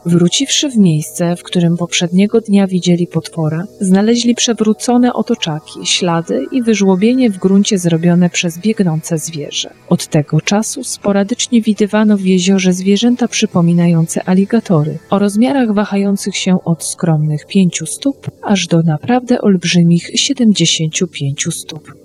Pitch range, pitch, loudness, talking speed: 170-215 Hz, 190 Hz, -13 LUFS, 125 wpm